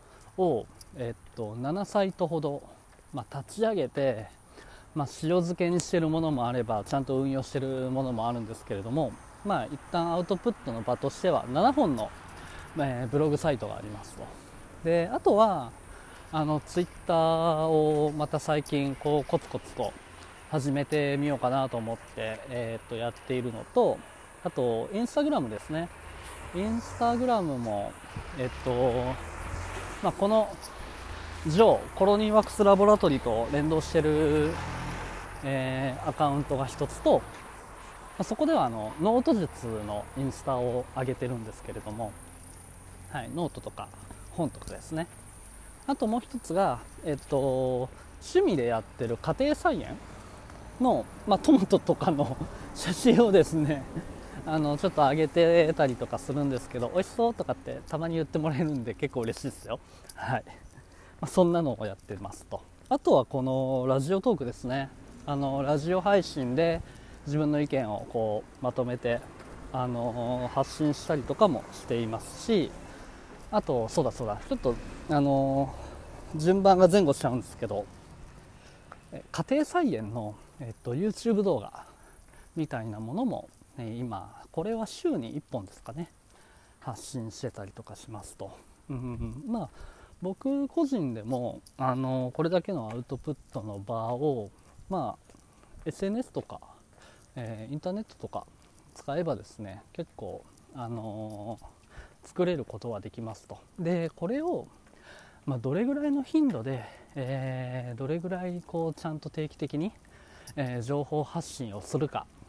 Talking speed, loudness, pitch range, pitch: 305 characters per minute, -29 LUFS, 120-170 Hz, 140 Hz